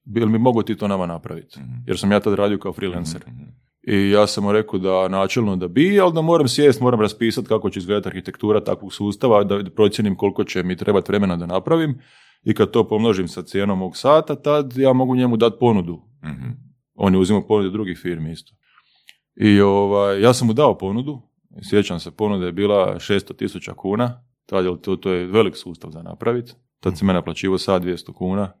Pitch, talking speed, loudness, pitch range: 100 Hz, 205 wpm, -19 LUFS, 95-120 Hz